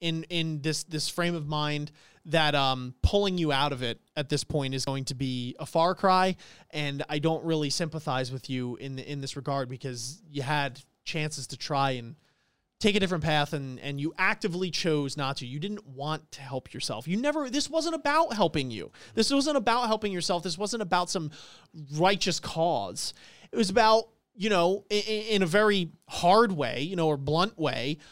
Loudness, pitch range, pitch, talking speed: -28 LUFS, 140-190 Hz, 155 Hz, 200 wpm